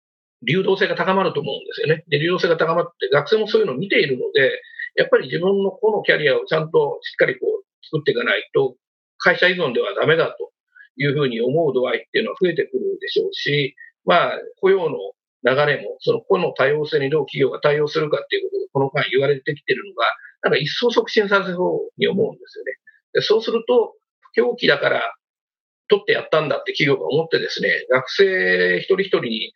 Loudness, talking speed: -19 LUFS, 425 characters per minute